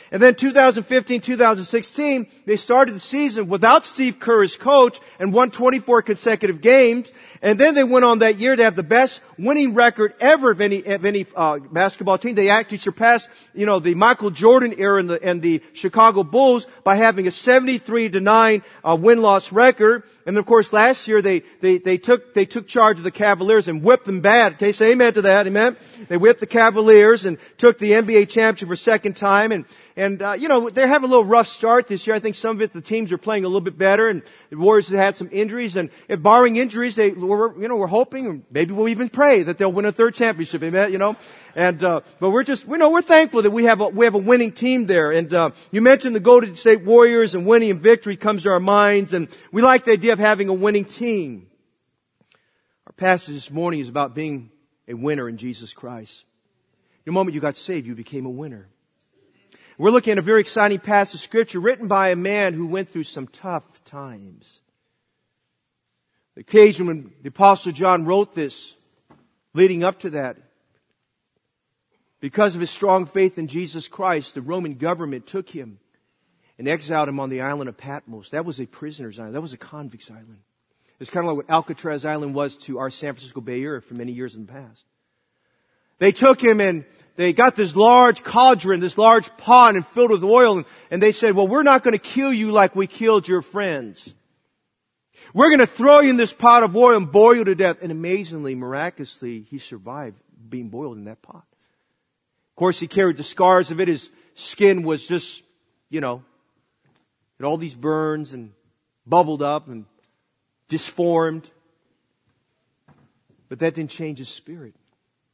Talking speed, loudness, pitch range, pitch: 205 wpm, -17 LUFS, 165-230 Hz, 195 Hz